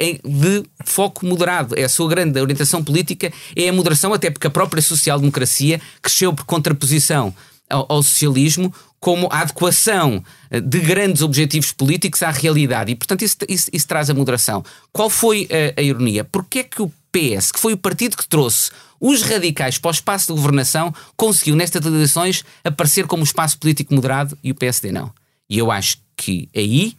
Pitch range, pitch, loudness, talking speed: 140-180 Hz, 155 Hz, -16 LUFS, 180 wpm